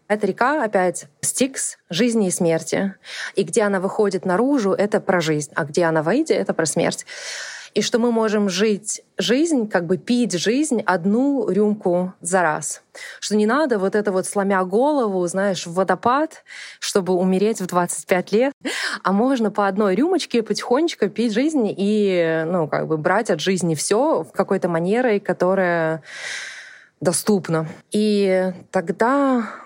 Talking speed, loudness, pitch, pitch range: 150 wpm, -20 LUFS, 200 Hz, 185-235 Hz